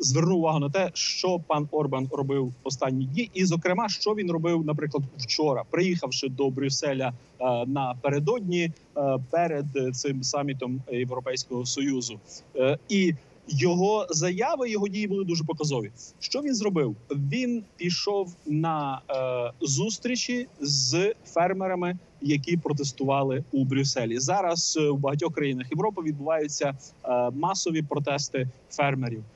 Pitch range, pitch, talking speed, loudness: 135-175 Hz, 145 Hz, 115 wpm, -27 LUFS